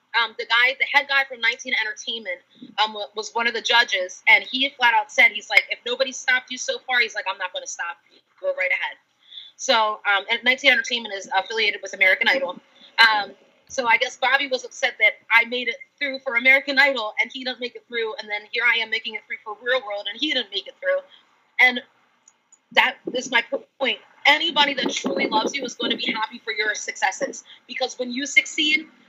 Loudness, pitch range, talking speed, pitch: -20 LUFS, 220-275 Hz, 225 wpm, 245 Hz